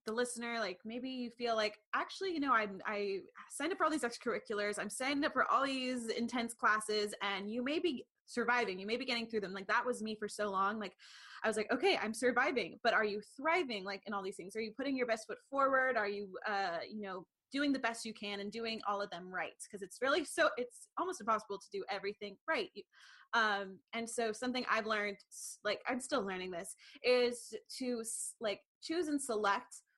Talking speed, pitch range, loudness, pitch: 220 wpm, 205-260 Hz, -37 LUFS, 230 Hz